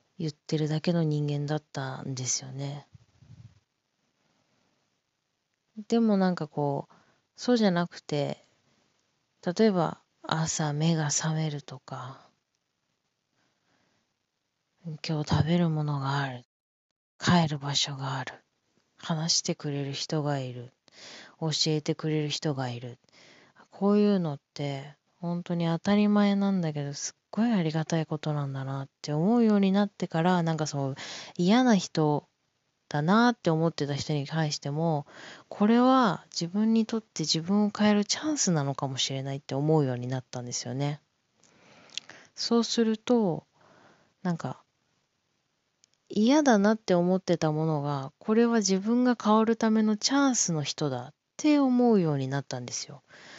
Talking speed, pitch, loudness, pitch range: 280 characters per minute, 160 Hz, -27 LUFS, 140-200 Hz